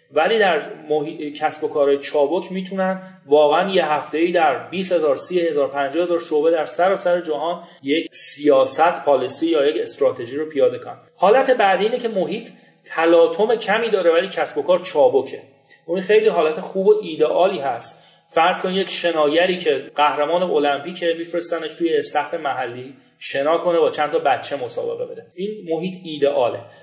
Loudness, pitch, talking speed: -19 LUFS, 180 Hz, 170 wpm